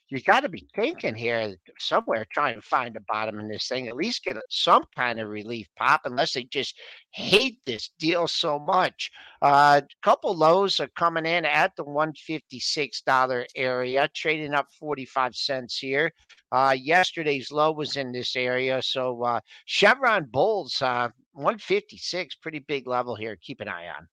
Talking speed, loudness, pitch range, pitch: 170 wpm, -25 LUFS, 125-155 Hz, 135 Hz